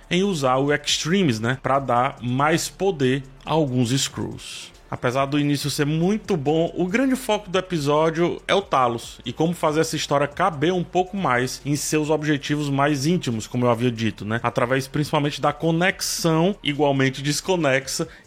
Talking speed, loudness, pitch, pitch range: 170 wpm, -22 LUFS, 145 Hz, 135-170 Hz